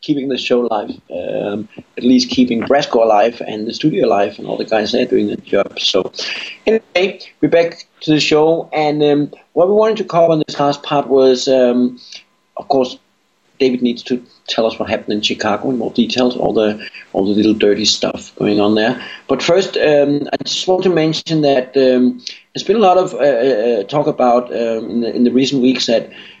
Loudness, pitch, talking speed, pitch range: -15 LUFS, 130 Hz, 210 wpm, 120-155 Hz